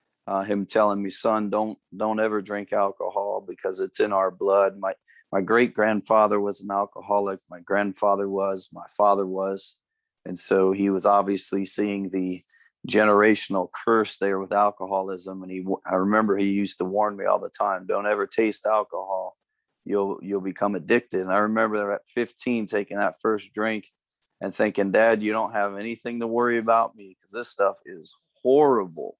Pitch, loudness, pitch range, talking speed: 100 Hz, -24 LUFS, 95-110 Hz, 175 wpm